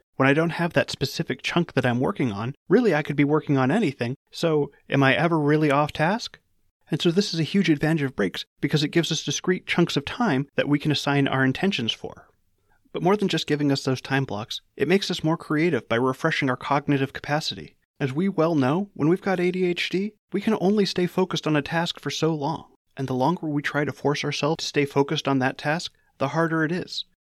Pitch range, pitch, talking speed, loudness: 140-170 Hz, 150 Hz, 230 wpm, -24 LUFS